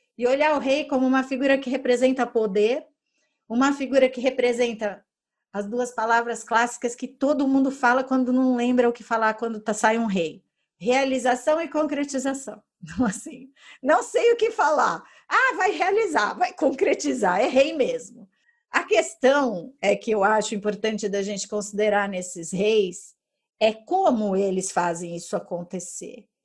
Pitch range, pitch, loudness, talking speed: 215-270 Hz, 245 Hz, -23 LUFS, 155 wpm